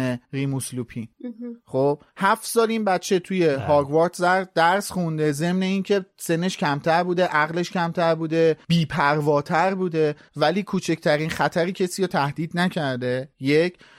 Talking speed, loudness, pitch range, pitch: 120 wpm, -22 LUFS, 145-185 Hz, 165 Hz